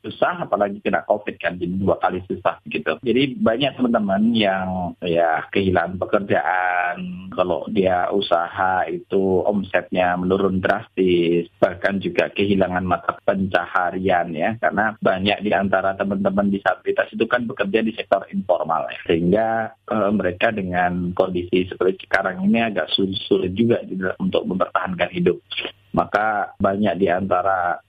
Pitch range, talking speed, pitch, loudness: 90-105 Hz, 135 wpm, 95 Hz, -21 LUFS